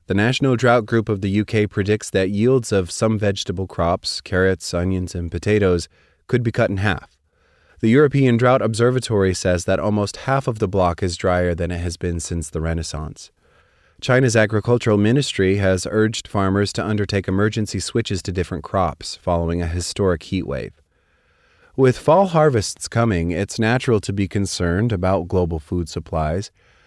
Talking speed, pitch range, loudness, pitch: 165 wpm, 90-110 Hz, -20 LUFS, 100 Hz